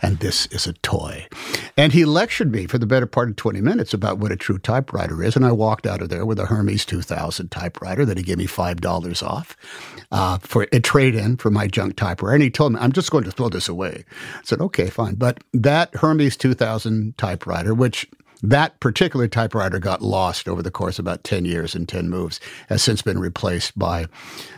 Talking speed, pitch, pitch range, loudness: 220 wpm, 110 Hz, 90-120 Hz, -20 LUFS